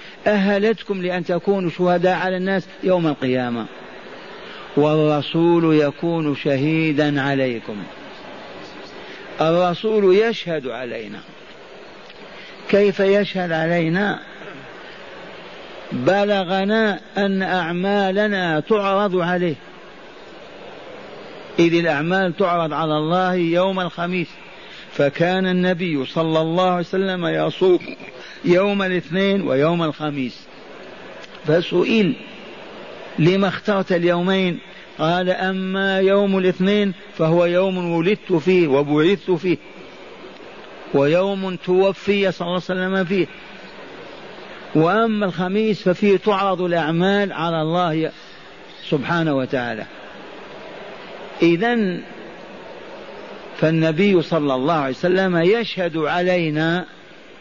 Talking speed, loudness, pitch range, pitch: 85 wpm, -19 LUFS, 160-195 Hz, 180 Hz